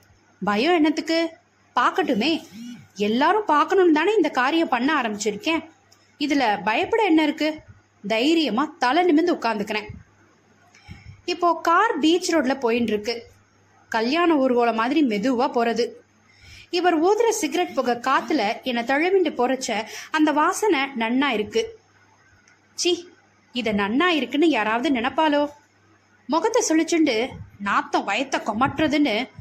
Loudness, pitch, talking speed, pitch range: -21 LUFS, 295 Hz, 105 wpm, 235-335 Hz